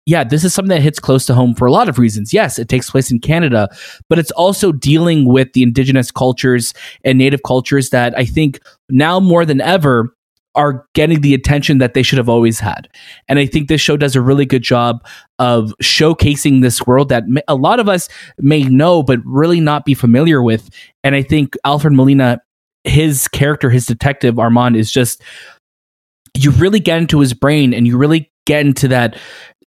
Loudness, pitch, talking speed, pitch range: -12 LUFS, 135 Hz, 200 wpm, 125-150 Hz